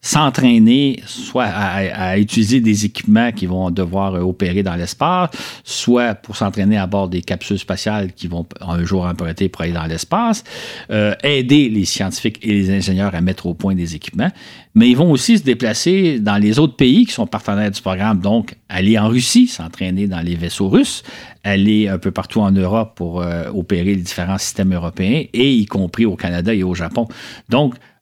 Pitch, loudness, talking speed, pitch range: 100 Hz, -16 LUFS, 190 wpm, 90-115 Hz